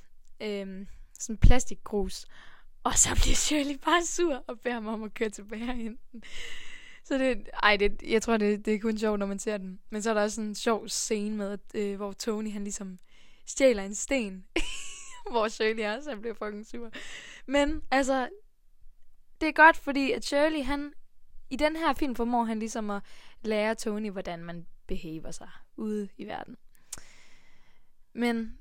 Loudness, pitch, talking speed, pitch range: -29 LUFS, 225 Hz, 180 wpm, 210-275 Hz